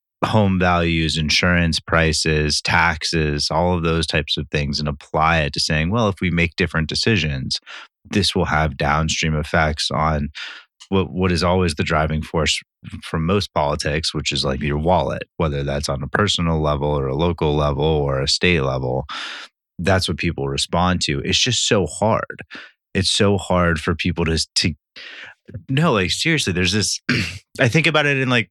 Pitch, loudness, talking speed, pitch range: 85 Hz, -19 LUFS, 175 wpm, 75-90 Hz